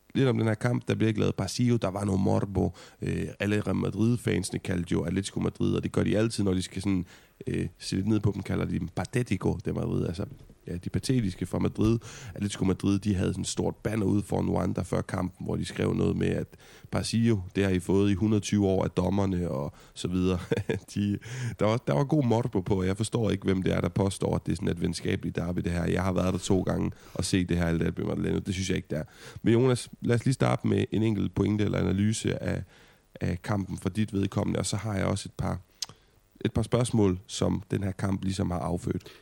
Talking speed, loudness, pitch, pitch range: 245 wpm, -29 LUFS, 100 Hz, 95-110 Hz